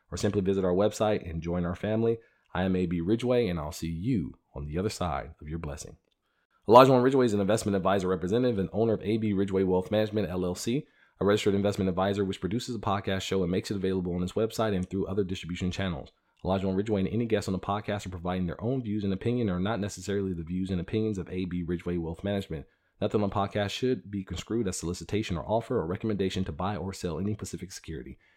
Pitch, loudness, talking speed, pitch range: 95 Hz, -29 LUFS, 225 wpm, 90-105 Hz